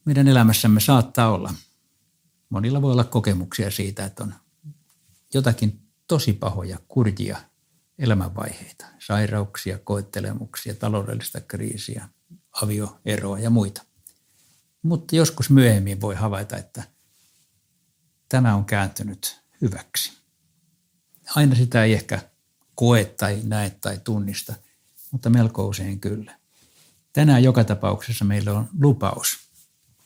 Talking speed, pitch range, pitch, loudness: 105 wpm, 100-135 Hz, 110 Hz, -22 LUFS